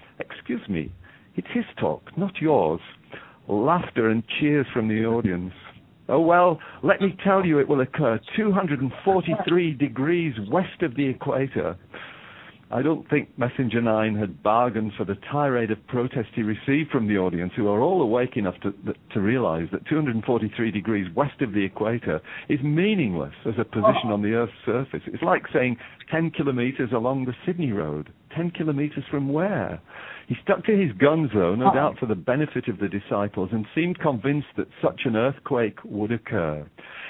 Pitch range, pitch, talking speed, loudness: 110-155 Hz, 130 Hz, 170 wpm, -24 LUFS